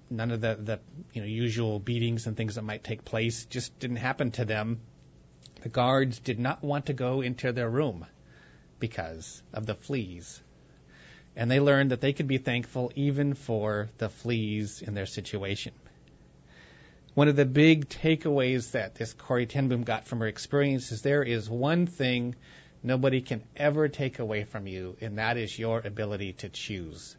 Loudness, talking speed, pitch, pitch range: -29 LUFS, 175 wpm, 115 Hz, 105-130 Hz